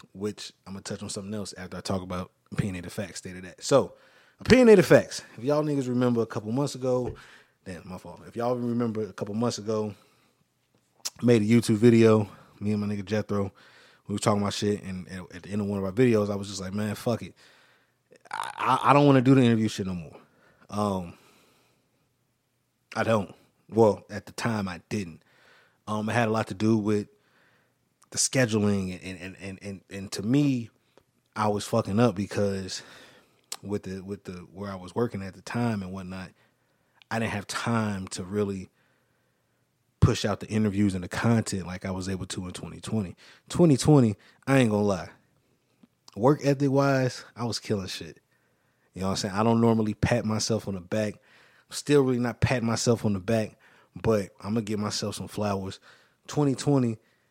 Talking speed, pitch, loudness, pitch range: 195 wpm, 105 Hz, -26 LUFS, 95-120 Hz